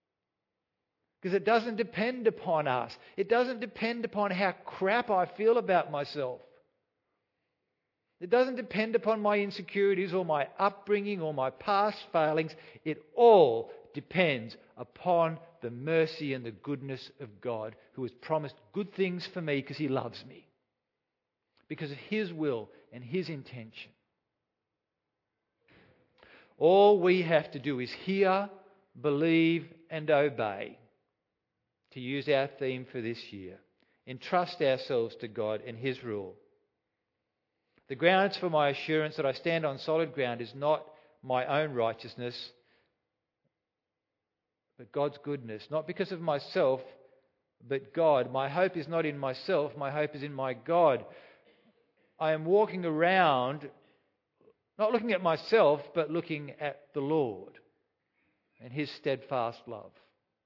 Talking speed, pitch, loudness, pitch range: 135 wpm, 155 Hz, -30 LUFS, 135-195 Hz